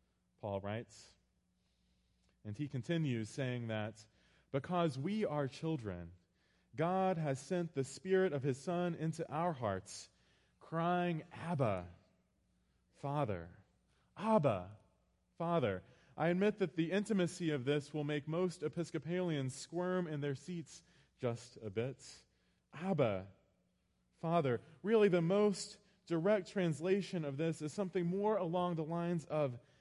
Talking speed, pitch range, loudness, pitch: 125 wpm, 110-175 Hz, -38 LUFS, 150 Hz